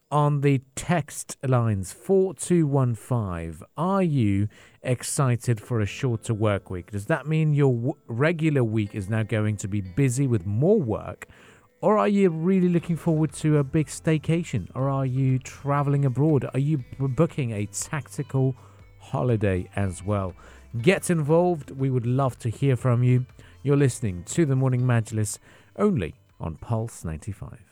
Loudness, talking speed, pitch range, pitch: -25 LUFS, 155 wpm, 110-150 Hz, 130 Hz